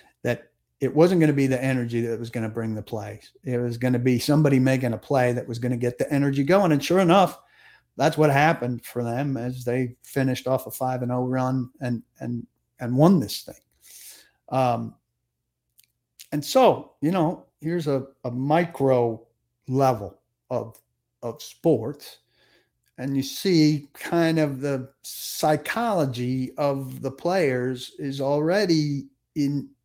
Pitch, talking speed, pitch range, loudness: 130 Hz, 165 wpm, 120-145 Hz, -24 LUFS